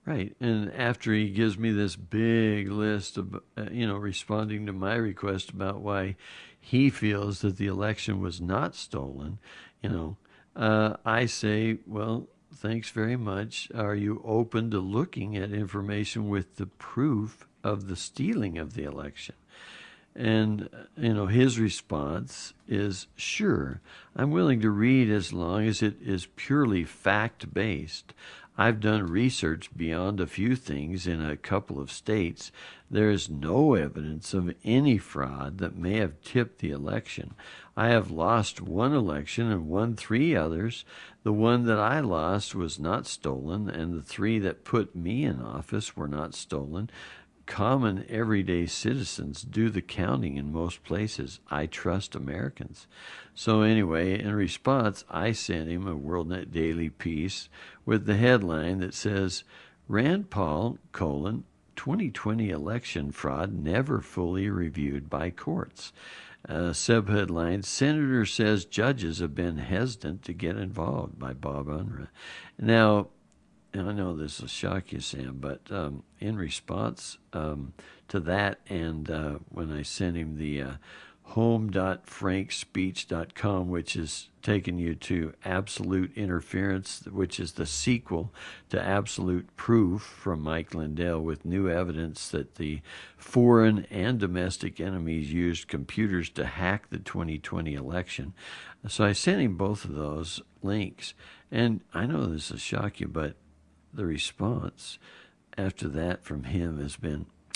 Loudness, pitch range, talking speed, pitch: -29 LUFS, 80-110 Hz, 145 wpm, 95 Hz